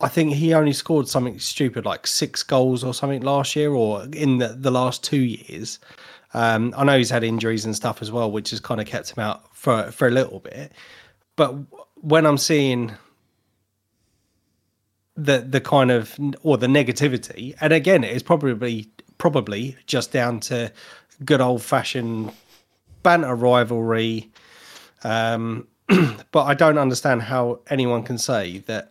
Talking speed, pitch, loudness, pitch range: 160 wpm, 125 Hz, -21 LUFS, 115-140 Hz